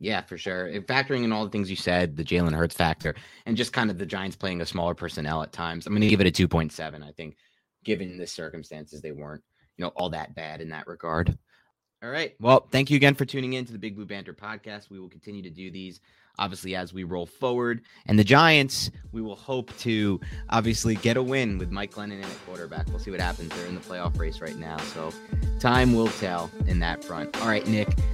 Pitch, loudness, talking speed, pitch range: 95 Hz, -26 LUFS, 245 wpm, 85-110 Hz